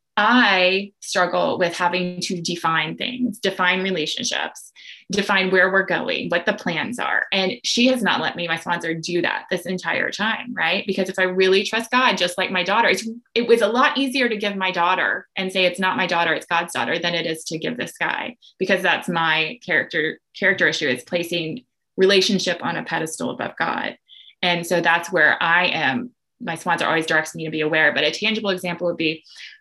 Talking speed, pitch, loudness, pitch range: 205 wpm, 185 Hz, -20 LUFS, 170-200 Hz